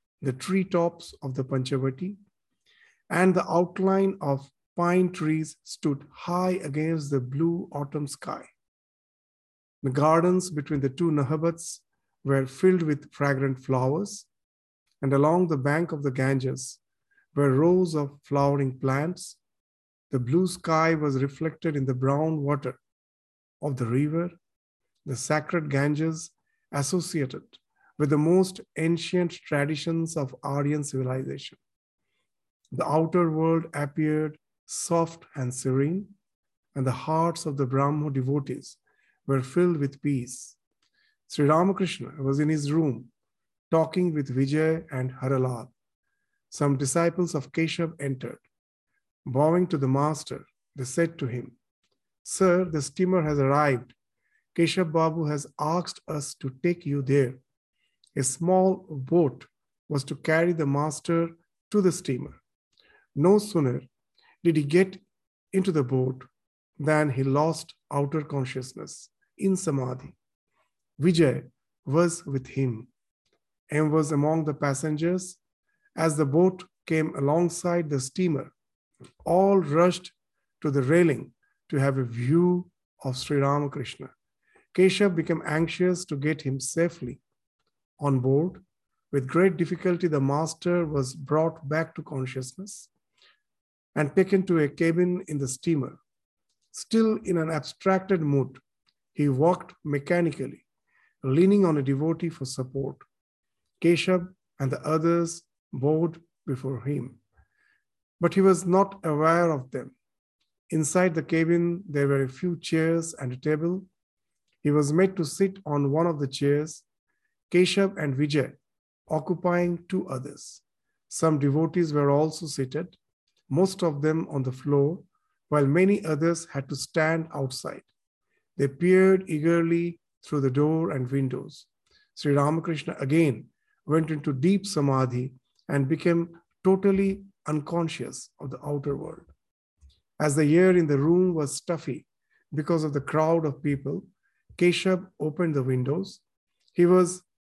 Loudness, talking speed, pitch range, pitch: -26 LUFS, 130 wpm, 140-175 Hz, 155 Hz